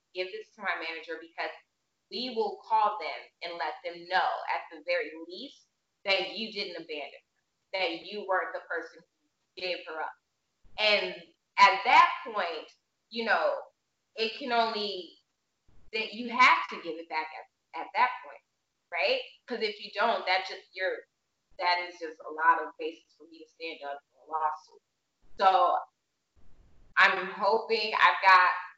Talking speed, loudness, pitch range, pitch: 165 wpm, -28 LUFS, 170-235 Hz, 190 Hz